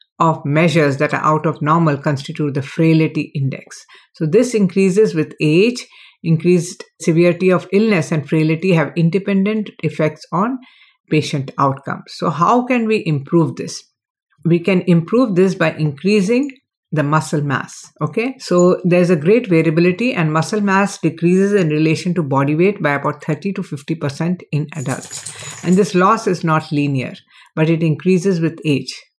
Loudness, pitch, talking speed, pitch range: -16 LUFS, 165 Hz, 160 wpm, 155-195 Hz